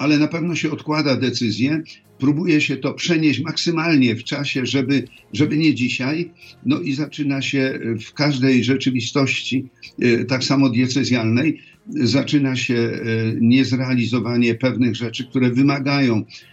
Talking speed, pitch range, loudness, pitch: 125 wpm, 125-145 Hz, -19 LUFS, 130 Hz